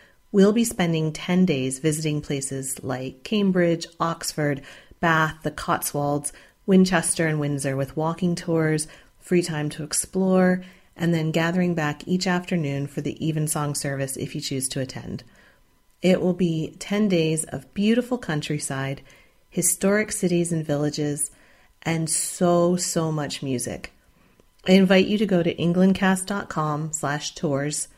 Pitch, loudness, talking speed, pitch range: 160 Hz, -23 LUFS, 135 wpm, 145-180 Hz